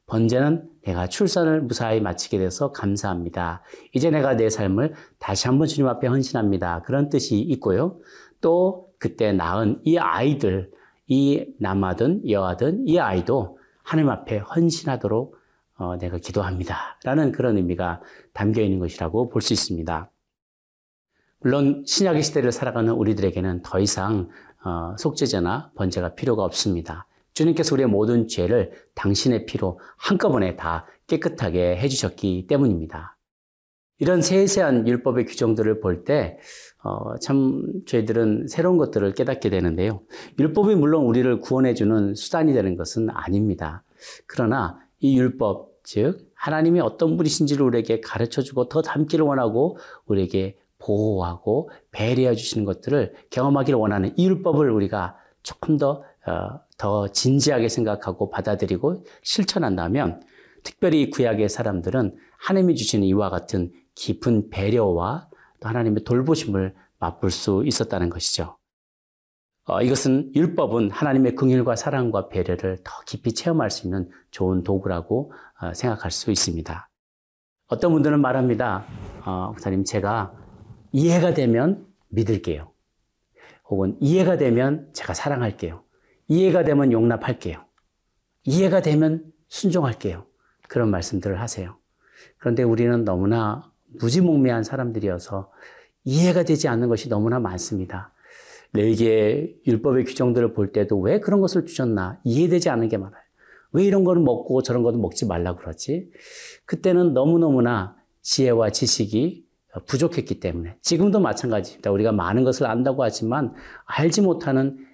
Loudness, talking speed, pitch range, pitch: -22 LUFS, 320 characters per minute, 95-140 Hz, 115 Hz